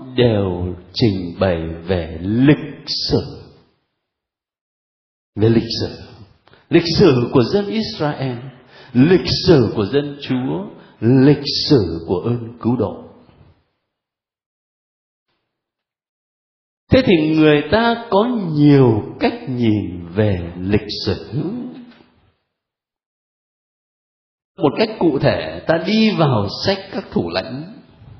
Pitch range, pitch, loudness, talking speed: 100-155 Hz, 125 Hz, -17 LUFS, 100 wpm